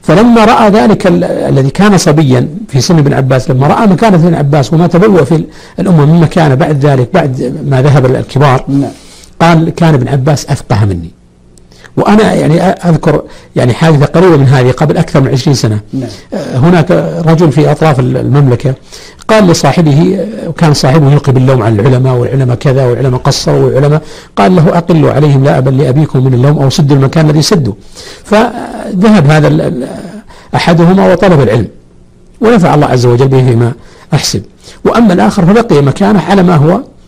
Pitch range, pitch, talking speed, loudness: 130-175 Hz, 150 Hz, 155 wpm, -7 LUFS